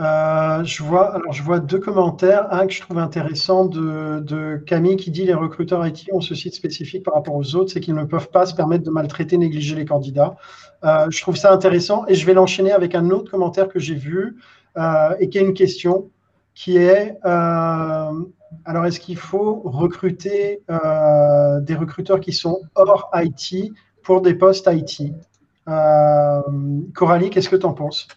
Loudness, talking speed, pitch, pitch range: -18 LUFS, 190 wpm, 175 Hz, 155-185 Hz